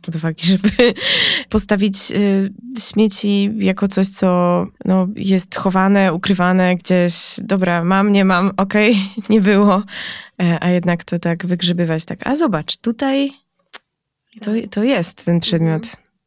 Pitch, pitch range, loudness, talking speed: 195 Hz, 180-210 Hz, -16 LUFS, 135 wpm